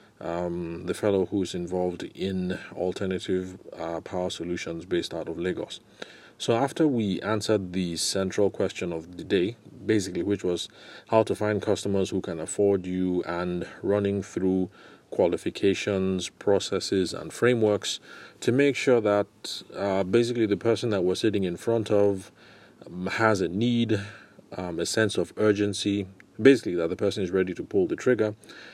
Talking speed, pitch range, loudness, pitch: 155 wpm, 90-105 Hz, -27 LUFS, 100 Hz